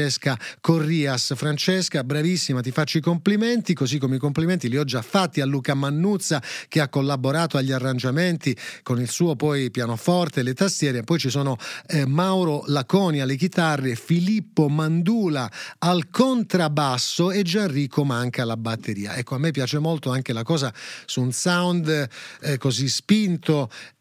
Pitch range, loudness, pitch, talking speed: 130-170 Hz, -23 LUFS, 150 Hz, 155 wpm